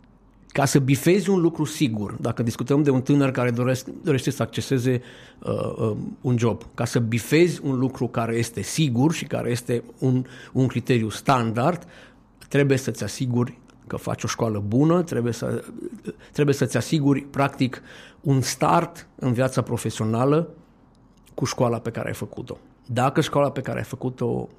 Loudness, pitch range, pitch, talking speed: -23 LUFS, 120-140 Hz, 130 Hz, 160 wpm